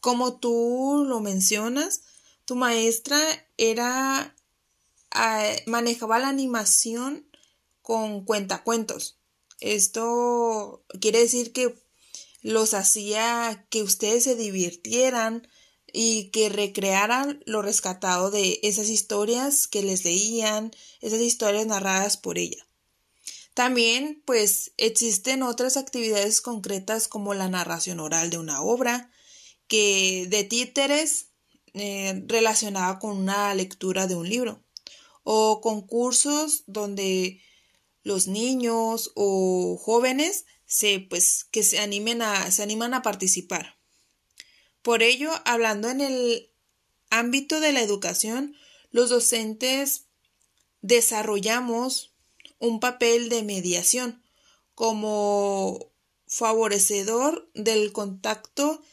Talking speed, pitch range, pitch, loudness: 100 wpm, 205-245 Hz, 225 Hz, -23 LUFS